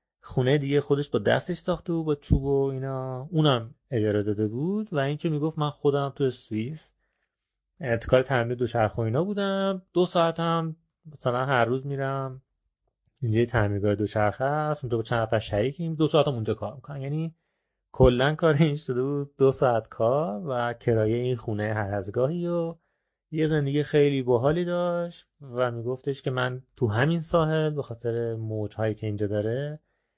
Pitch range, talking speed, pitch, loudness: 115-155 Hz, 165 wpm, 135 Hz, -26 LUFS